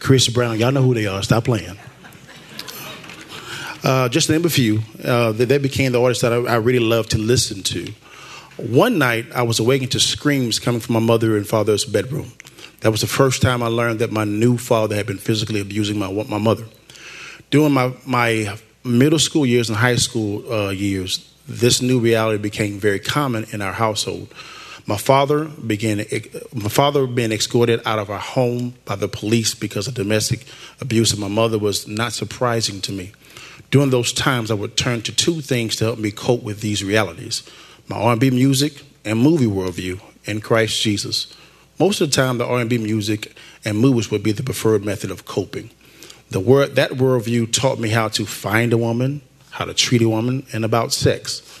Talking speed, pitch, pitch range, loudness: 195 wpm, 115 Hz, 110-125 Hz, -19 LUFS